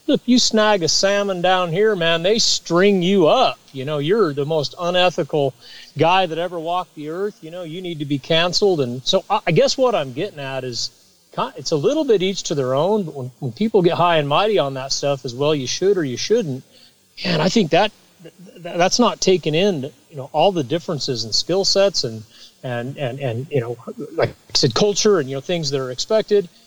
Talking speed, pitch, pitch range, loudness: 225 wpm, 170 Hz, 140-195 Hz, -19 LUFS